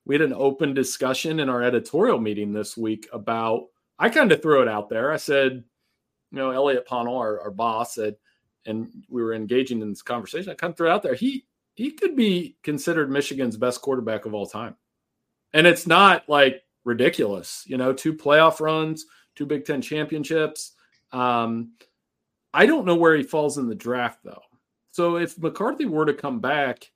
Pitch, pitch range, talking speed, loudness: 135 Hz, 120-155 Hz, 190 wpm, -22 LUFS